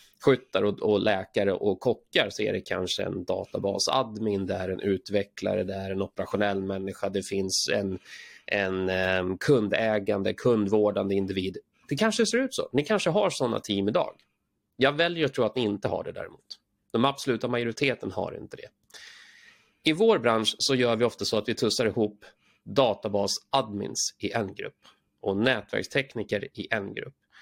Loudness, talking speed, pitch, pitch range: -27 LUFS, 160 wpm, 105 Hz, 100-125 Hz